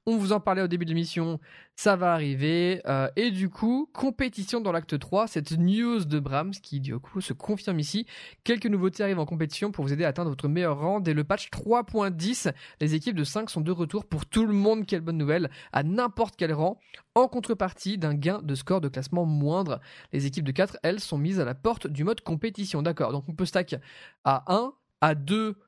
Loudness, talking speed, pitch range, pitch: -28 LUFS, 220 wpm, 155-210 Hz, 180 Hz